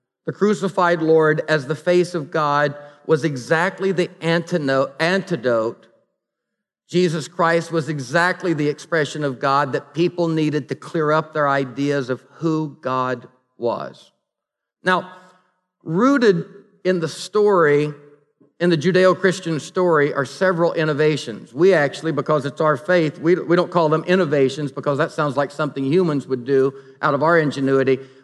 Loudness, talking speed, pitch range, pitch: -19 LUFS, 145 wpm, 145-175 Hz, 155 Hz